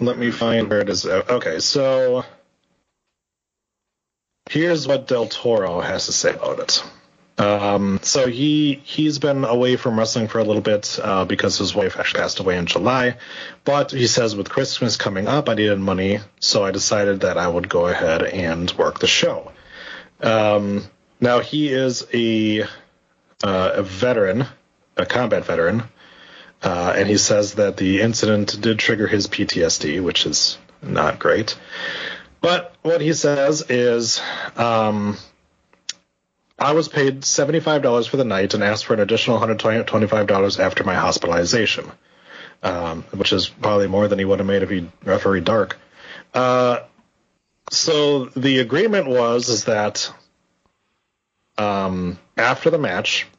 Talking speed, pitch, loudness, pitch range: 150 wpm, 115 Hz, -19 LUFS, 105-135 Hz